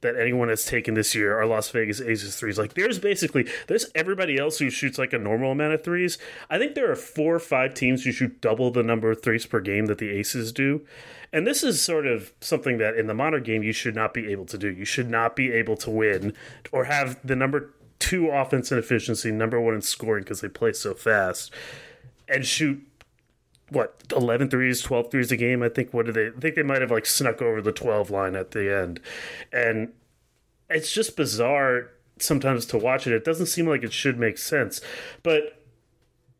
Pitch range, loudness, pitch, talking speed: 110-140 Hz, -24 LUFS, 125 Hz, 220 wpm